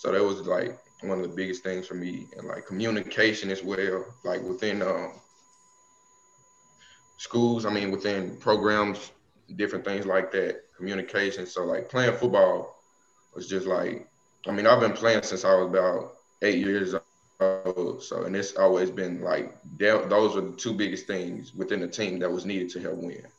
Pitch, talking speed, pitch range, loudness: 95 Hz, 175 wpm, 95-115 Hz, -27 LUFS